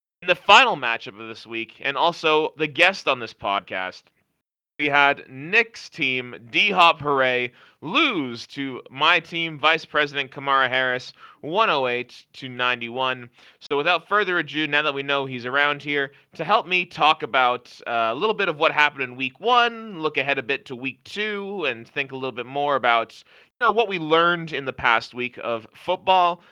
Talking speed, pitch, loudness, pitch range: 180 wpm, 145 Hz, -21 LUFS, 125-170 Hz